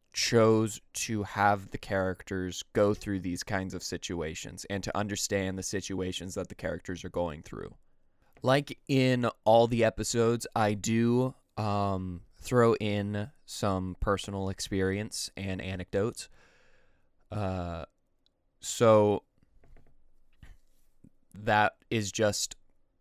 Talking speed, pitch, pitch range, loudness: 110 wpm, 100 Hz, 90-110 Hz, -30 LUFS